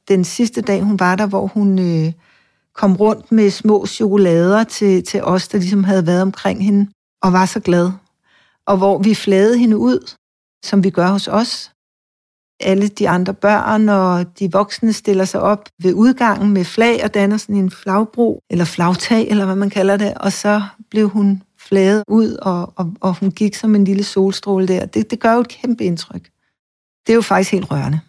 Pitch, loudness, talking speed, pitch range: 200 Hz, -15 LUFS, 195 wpm, 190-210 Hz